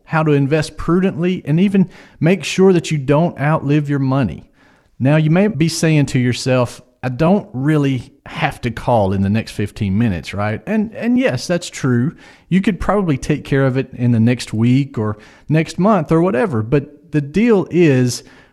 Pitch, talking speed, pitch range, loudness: 145 Hz, 190 wpm, 125-170 Hz, -16 LUFS